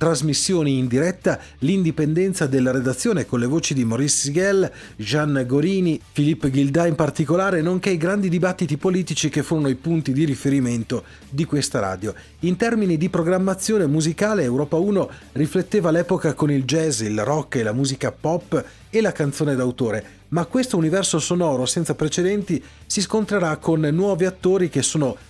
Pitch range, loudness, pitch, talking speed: 140-180 Hz, -21 LUFS, 160 Hz, 155 wpm